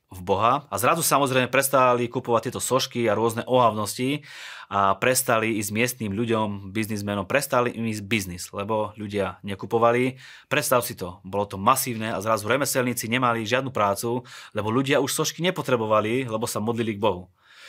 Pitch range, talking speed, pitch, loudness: 105-130 Hz, 160 wpm, 115 Hz, -24 LUFS